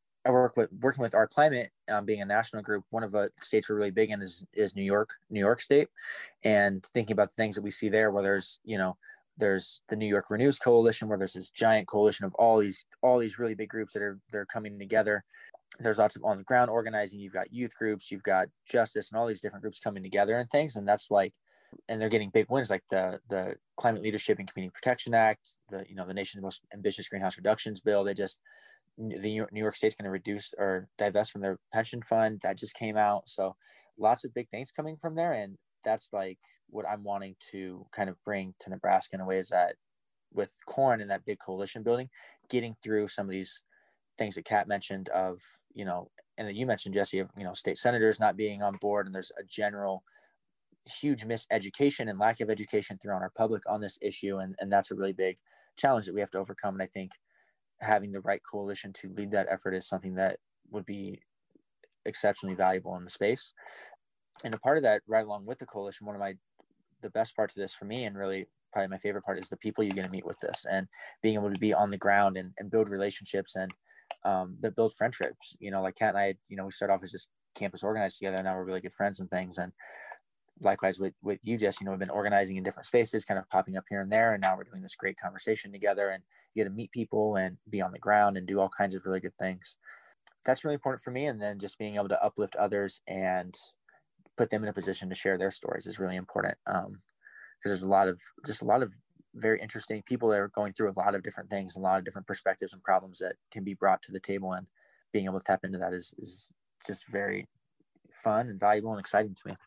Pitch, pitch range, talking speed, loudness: 100 Hz, 95-110 Hz, 245 wpm, -31 LUFS